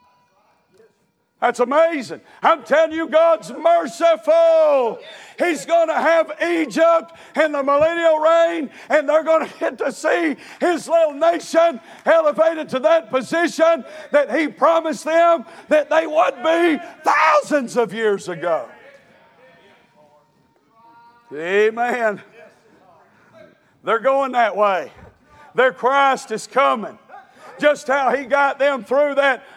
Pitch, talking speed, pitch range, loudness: 295 Hz, 120 wpm, 245-325 Hz, -18 LUFS